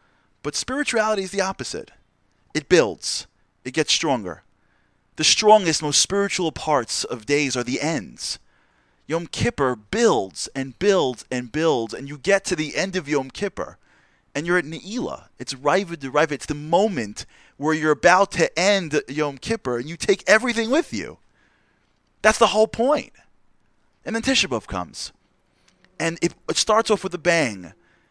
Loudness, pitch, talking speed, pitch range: -21 LUFS, 160 Hz, 160 wpm, 140-200 Hz